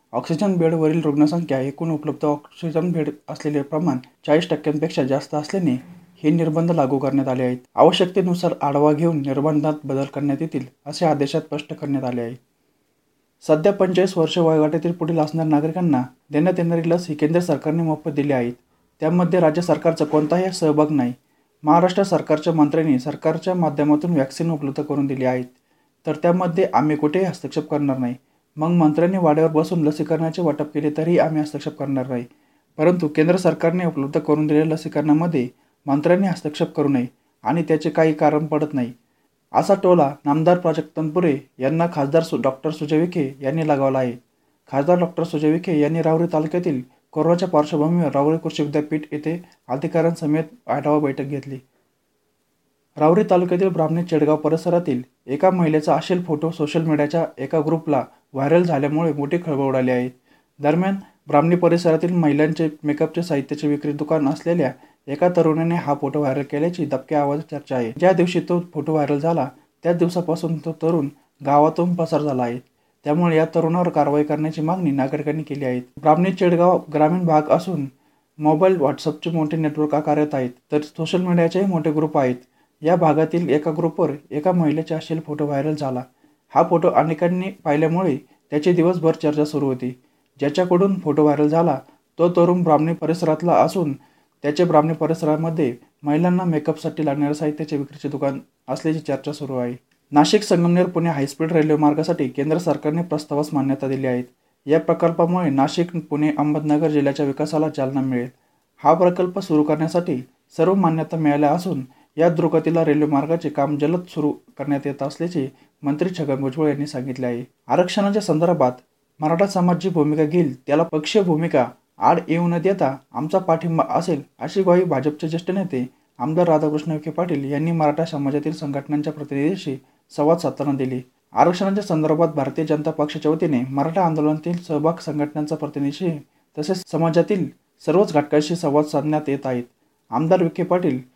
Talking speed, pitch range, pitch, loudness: 145 wpm, 145-165 Hz, 155 Hz, -20 LUFS